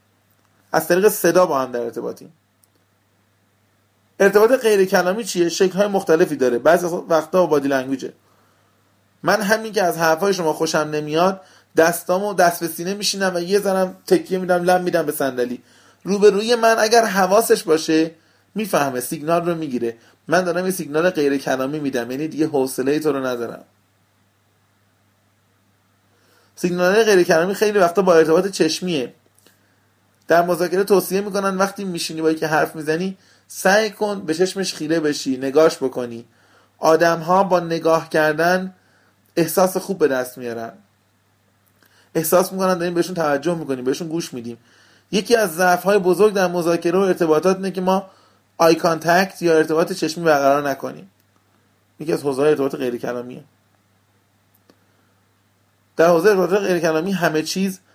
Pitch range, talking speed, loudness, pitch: 115-185 Hz, 145 wpm, -18 LUFS, 160 Hz